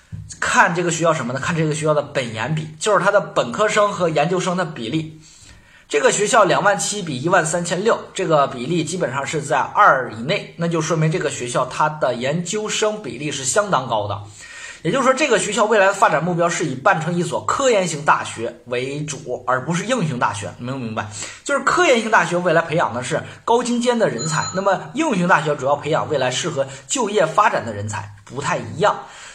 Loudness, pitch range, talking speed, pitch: -19 LUFS, 135-200 Hz, 325 characters per minute, 165 Hz